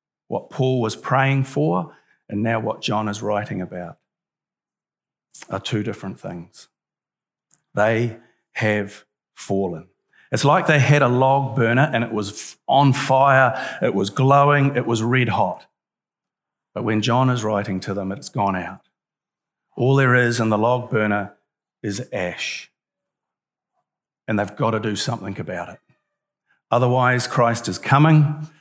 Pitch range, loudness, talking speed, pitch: 105-135 Hz, -20 LUFS, 145 wpm, 120 Hz